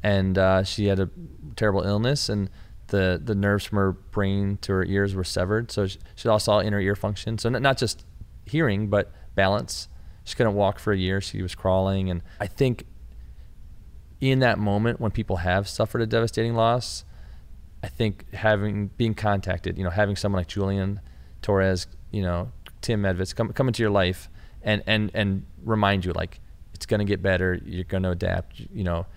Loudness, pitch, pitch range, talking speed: -25 LUFS, 100 Hz, 95-105 Hz, 190 wpm